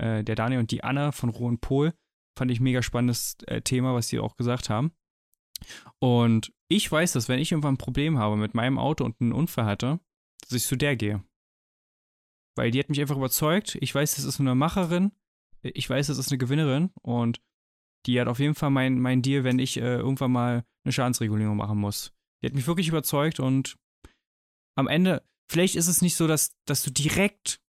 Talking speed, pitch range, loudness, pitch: 205 wpm, 120-145 Hz, -26 LUFS, 130 Hz